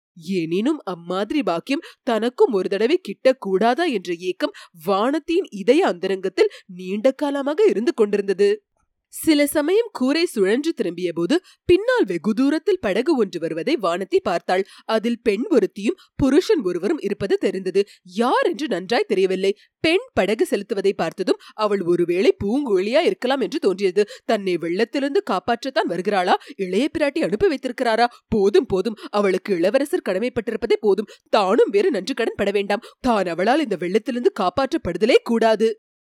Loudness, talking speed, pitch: -21 LUFS, 125 wpm, 235 Hz